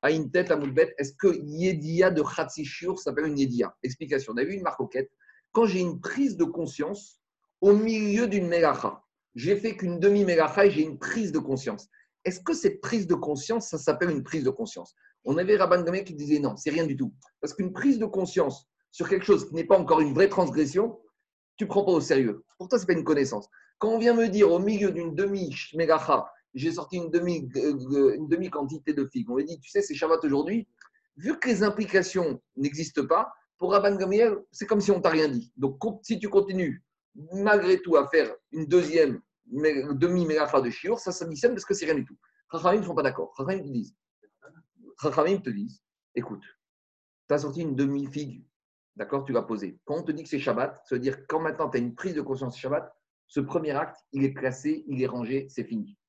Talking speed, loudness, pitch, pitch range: 215 wpm, -26 LUFS, 170 Hz, 145-205 Hz